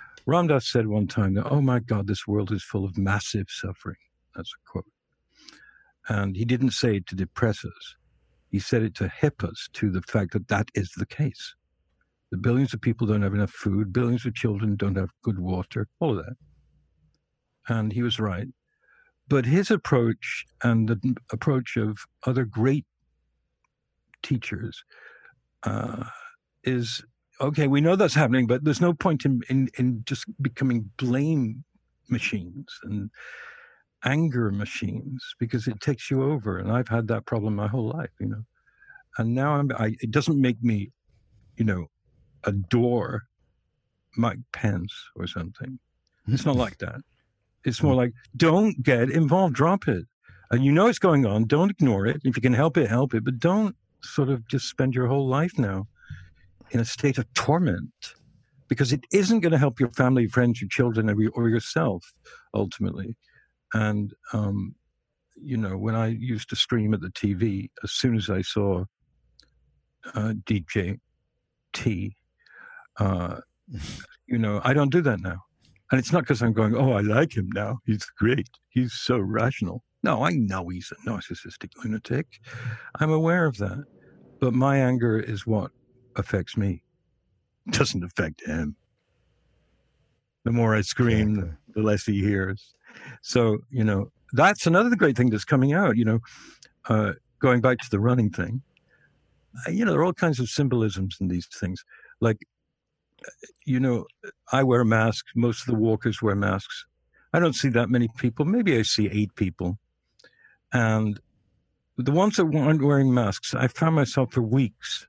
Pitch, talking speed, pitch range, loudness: 120 Hz, 170 wpm, 105-135 Hz, -25 LUFS